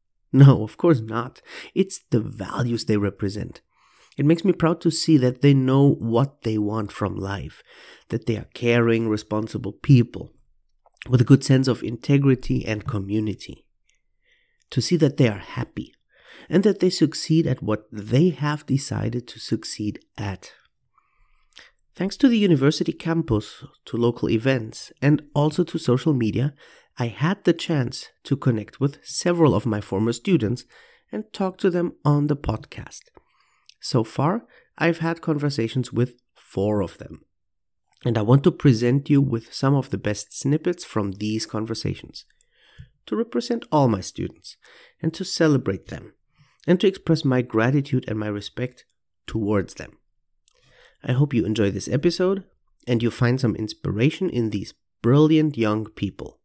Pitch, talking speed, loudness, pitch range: 125 Hz, 155 wpm, -22 LUFS, 110-155 Hz